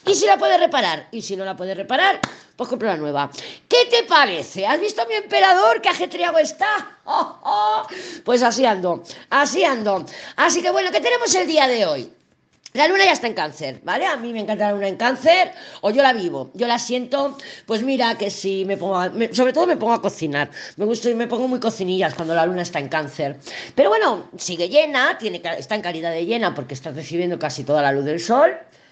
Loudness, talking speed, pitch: -19 LUFS, 230 wpm, 230 Hz